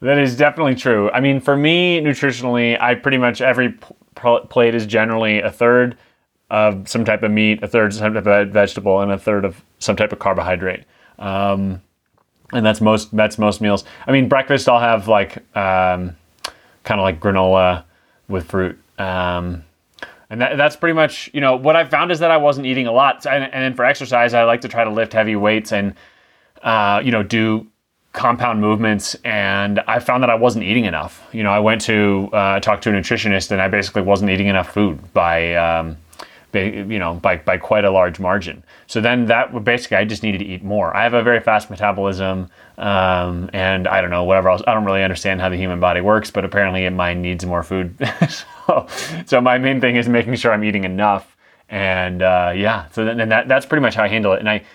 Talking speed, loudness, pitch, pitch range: 220 wpm, -17 LUFS, 105 Hz, 95-120 Hz